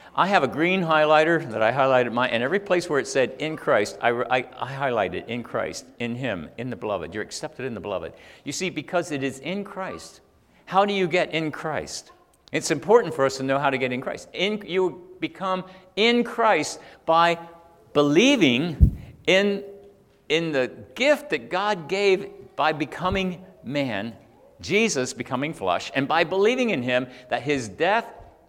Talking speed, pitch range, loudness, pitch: 180 wpm, 135-195 Hz, -24 LUFS, 170 Hz